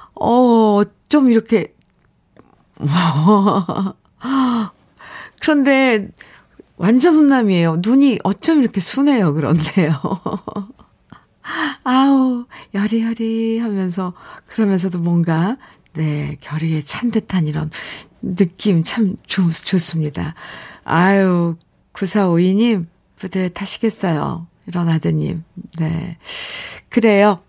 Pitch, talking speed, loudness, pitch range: 195 Hz, 185 characters per minute, -17 LUFS, 170-230 Hz